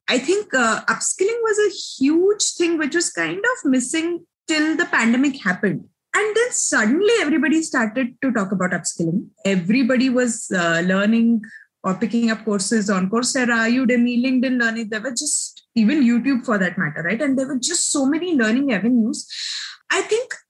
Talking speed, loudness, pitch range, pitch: 170 wpm, -19 LUFS, 225-335 Hz, 260 Hz